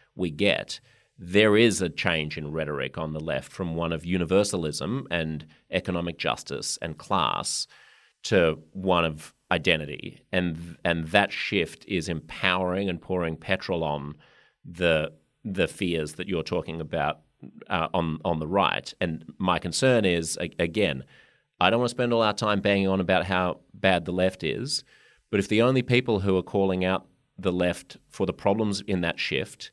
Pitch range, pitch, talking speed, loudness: 80-100 Hz, 90 Hz, 175 wpm, -26 LUFS